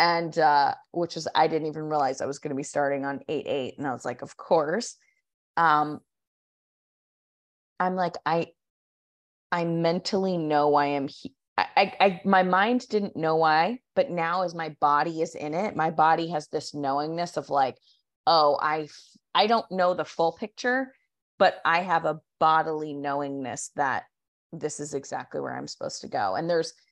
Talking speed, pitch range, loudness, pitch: 180 wpm, 145-175 Hz, -26 LUFS, 160 Hz